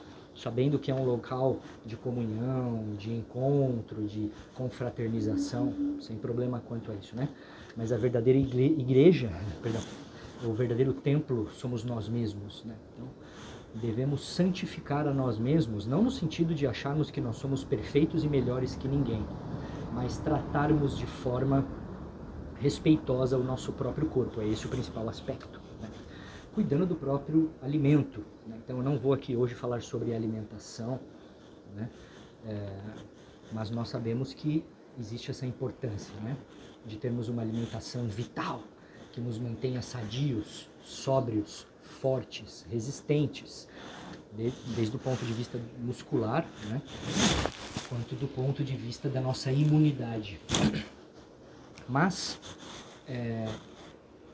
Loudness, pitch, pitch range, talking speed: -32 LUFS, 125 Hz, 110-140 Hz, 130 wpm